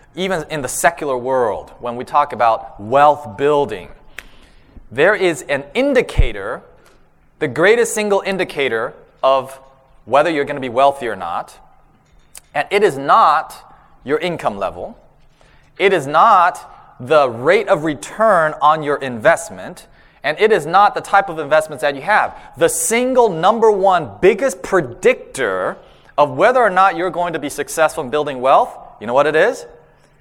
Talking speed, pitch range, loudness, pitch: 155 wpm, 140-195 Hz, -16 LUFS, 155 Hz